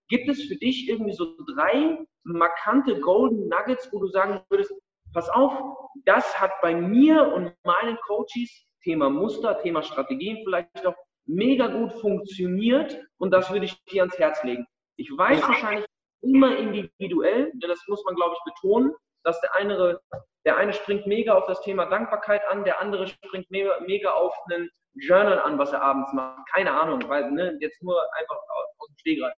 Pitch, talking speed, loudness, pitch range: 205 Hz, 175 wpm, -24 LUFS, 180-265 Hz